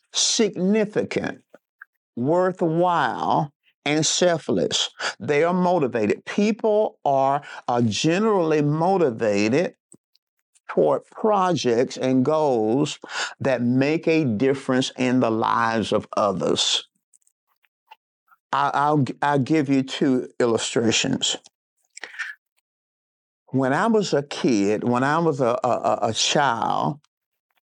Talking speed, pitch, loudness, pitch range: 95 wpm, 150 Hz, -21 LUFS, 130-180 Hz